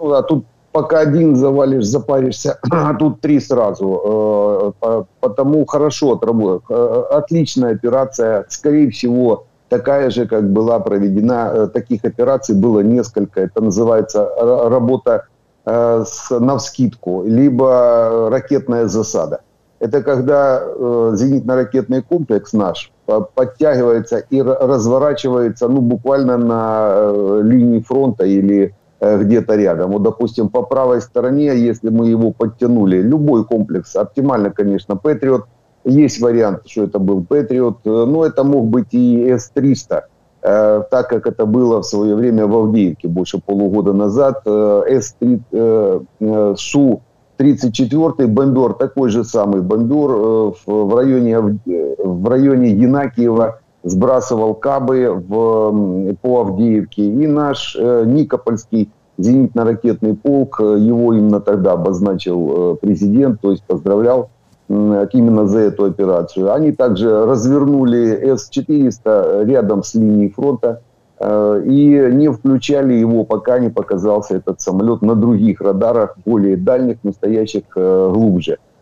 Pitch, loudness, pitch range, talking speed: 120 Hz, -14 LUFS, 105-135 Hz, 115 wpm